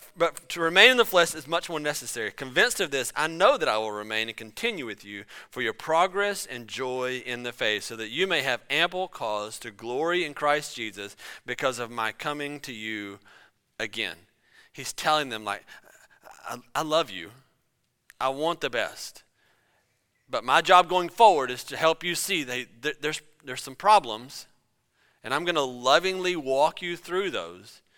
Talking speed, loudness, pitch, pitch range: 190 wpm, -26 LUFS, 140 Hz, 120-170 Hz